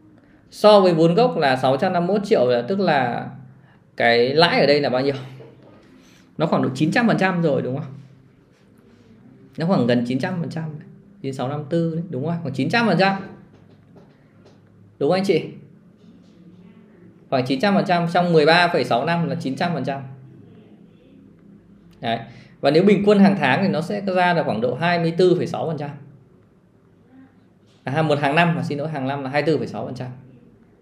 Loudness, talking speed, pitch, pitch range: -19 LUFS, 155 wpm, 165 Hz, 135-185 Hz